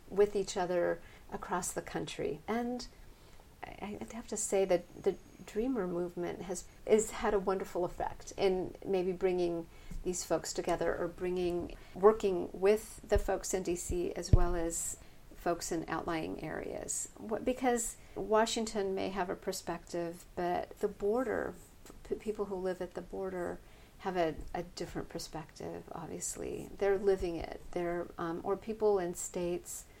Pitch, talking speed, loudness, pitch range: 185 Hz, 145 wpm, -35 LUFS, 175-205 Hz